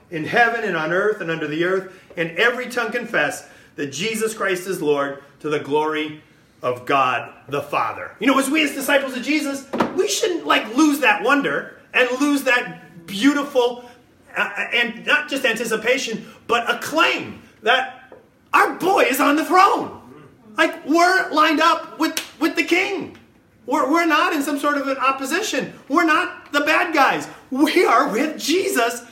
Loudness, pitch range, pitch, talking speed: -19 LUFS, 210-310 Hz, 260 Hz, 175 wpm